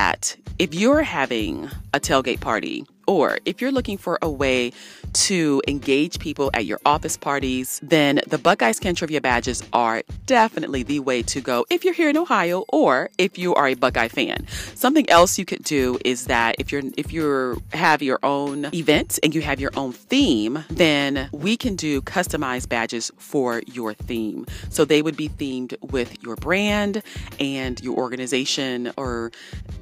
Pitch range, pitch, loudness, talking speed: 125-175 Hz, 140 Hz, -21 LUFS, 175 wpm